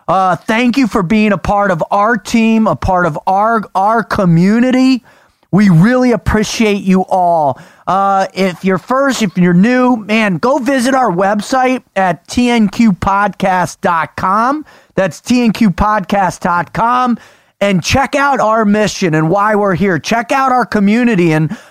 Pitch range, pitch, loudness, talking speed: 185-240 Hz, 210 Hz, -12 LUFS, 140 wpm